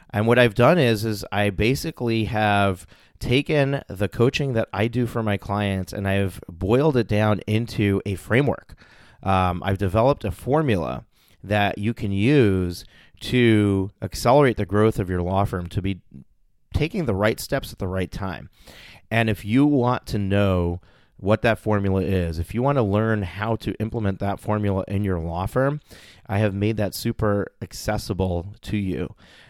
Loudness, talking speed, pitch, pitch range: -22 LUFS, 175 wpm, 105 Hz, 95-115 Hz